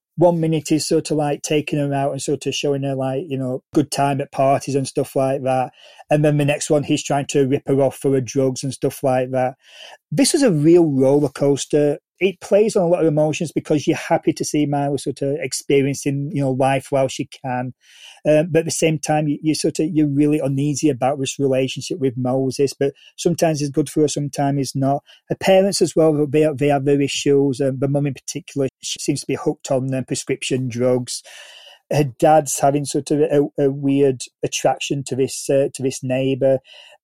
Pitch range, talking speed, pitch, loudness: 135-150 Hz, 220 wpm, 140 Hz, -19 LUFS